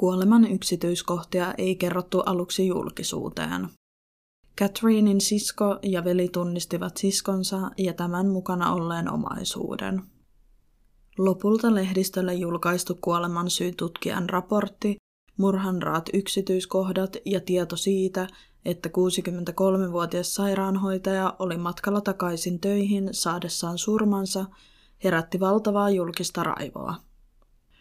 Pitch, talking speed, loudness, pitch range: 185 Hz, 90 wpm, -26 LUFS, 175-195 Hz